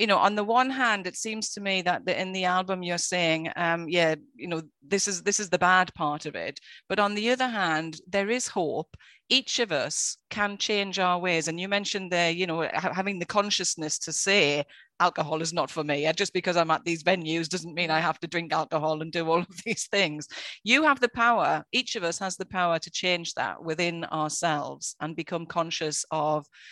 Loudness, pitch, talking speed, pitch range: -26 LUFS, 180 Hz, 220 wpm, 165-200 Hz